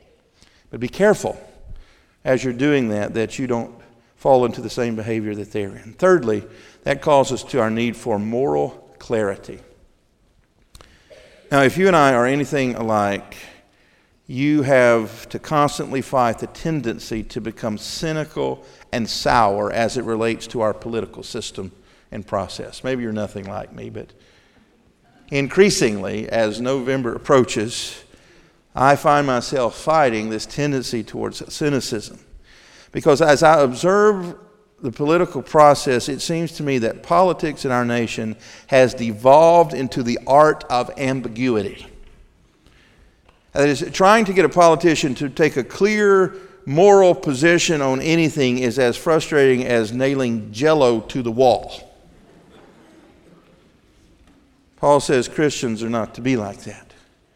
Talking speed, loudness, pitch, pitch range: 135 wpm, -18 LUFS, 130 Hz, 115-150 Hz